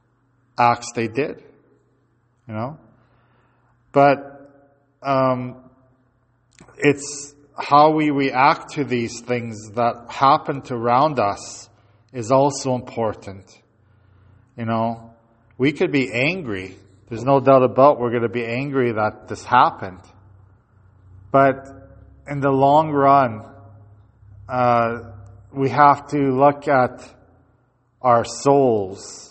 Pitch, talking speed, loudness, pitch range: 120 Hz, 105 wpm, -19 LUFS, 110-135 Hz